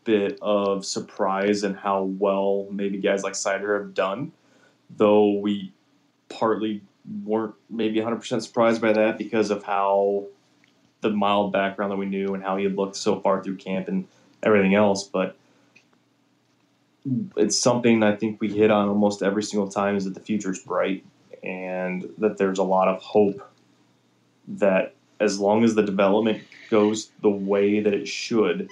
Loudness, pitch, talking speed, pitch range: -23 LUFS, 100 Hz, 165 wpm, 100-105 Hz